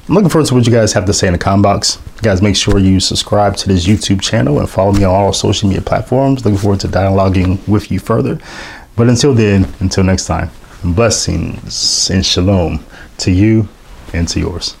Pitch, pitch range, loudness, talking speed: 100 Hz, 95-110 Hz, -12 LUFS, 215 wpm